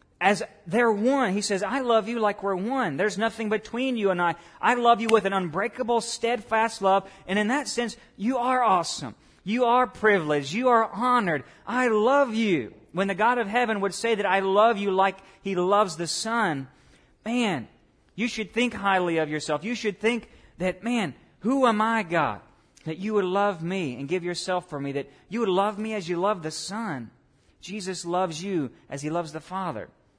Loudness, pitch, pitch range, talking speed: -25 LUFS, 205 Hz, 175-230 Hz, 200 wpm